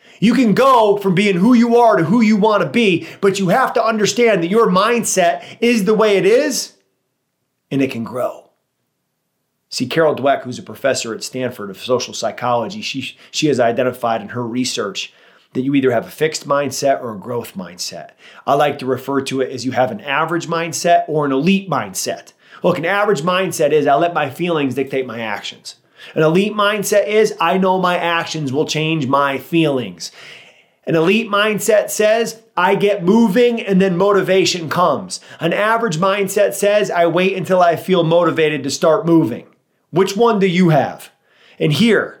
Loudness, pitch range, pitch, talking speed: -16 LUFS, 140-205 Hz, 175 Hz, 185 wpm